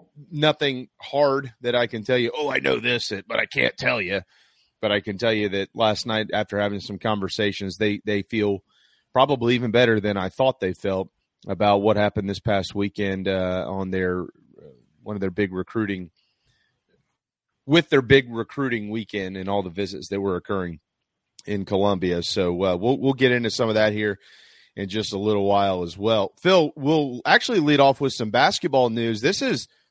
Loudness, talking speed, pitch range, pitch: -23 LUFS, 195 wpm, 100-125 Hz, 105 Hz